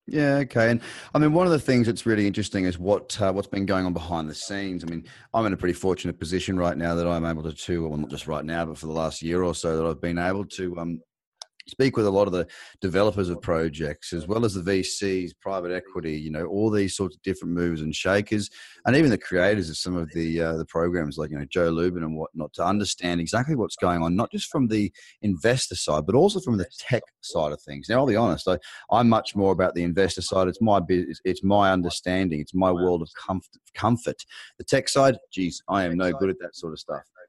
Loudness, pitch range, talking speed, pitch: -25 LUFS, 85-100 Hz, 250 wpm, 90 Hz